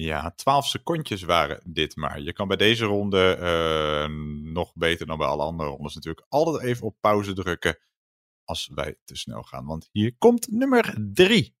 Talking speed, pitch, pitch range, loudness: 180 wpm, 85 Hz, 80-110 Hz, -24 LUFS